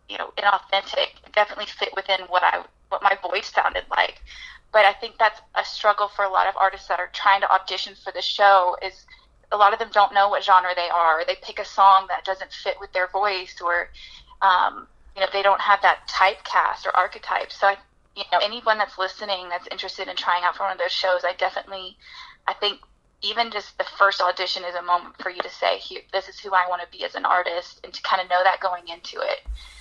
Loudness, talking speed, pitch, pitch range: -22 LUFS, 235 wpm, 195 Hz, 185-205 Hz